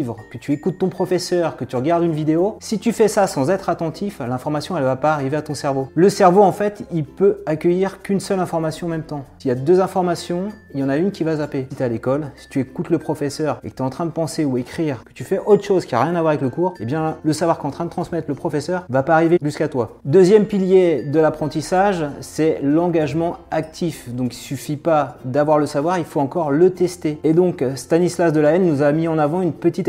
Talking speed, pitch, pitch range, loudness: 265 wpm, 160 Hz, 145-180 Hz, -19 LUFS